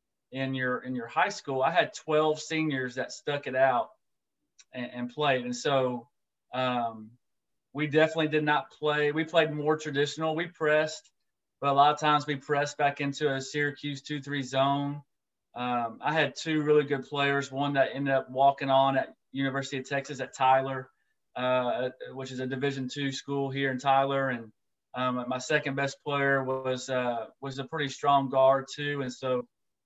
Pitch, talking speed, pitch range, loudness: 135 Hz, 180 wpm, 130-145 Hz, -28 LUFS